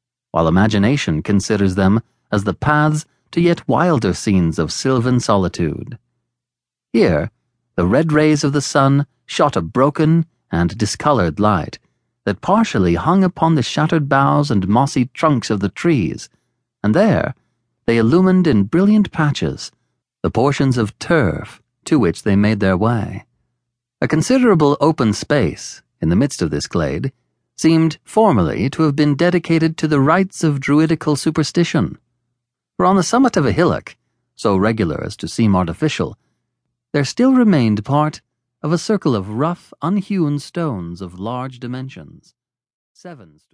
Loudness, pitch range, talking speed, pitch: -17 LUFS, 110-160 Hz, 150 wpm, 140 Hz